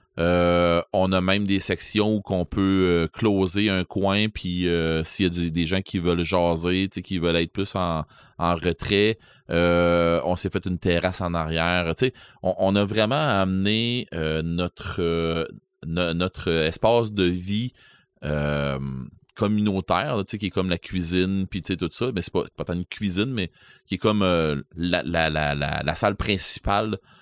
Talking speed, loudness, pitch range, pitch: 180 wpm, -23 LUFS, 85-100 Hz, 90 Hz